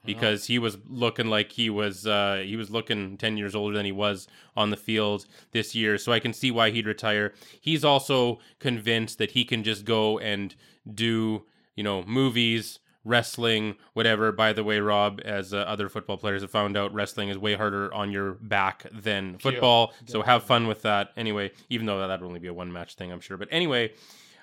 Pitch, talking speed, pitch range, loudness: 105 Hz, 210 wpm, 100-115 Hz, -26 LUFS